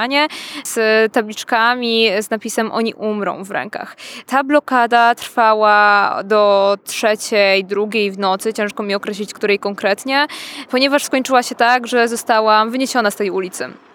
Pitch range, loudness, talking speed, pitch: 210-250 Hz, -16 LUFS, 135 wpm, 225 Hz